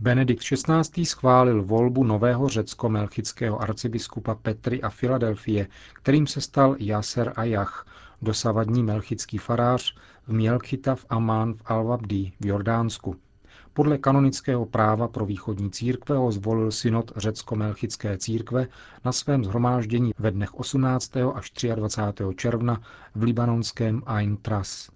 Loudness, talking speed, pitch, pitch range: -25 LUFS, 120 wpm, 115 Hz, 105-125 Hz